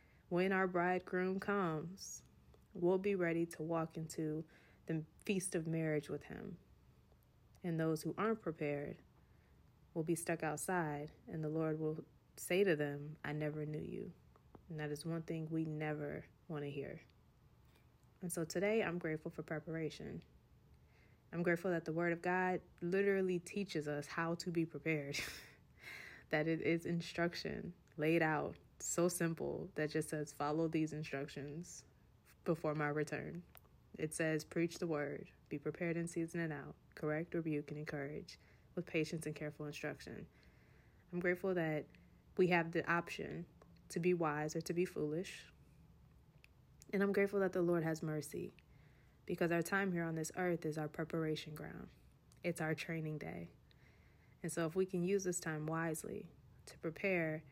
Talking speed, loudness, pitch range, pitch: 160 wpm, -40 LUFS, 150-175 Hz, 165 Hz